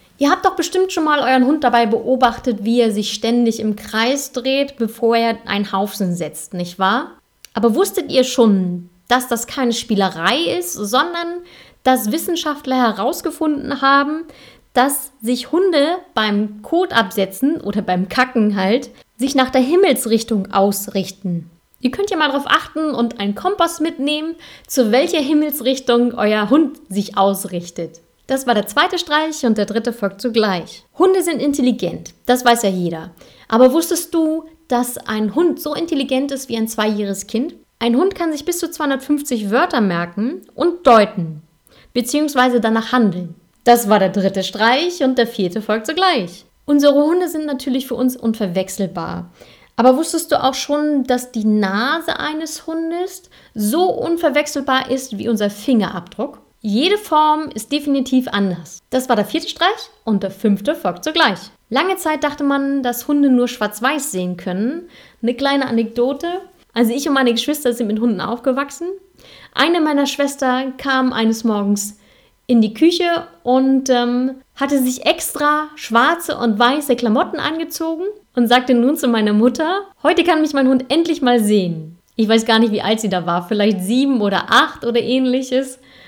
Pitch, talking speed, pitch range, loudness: 250 Hz, 160 wpm, 215-300 Hz, -17 LUFS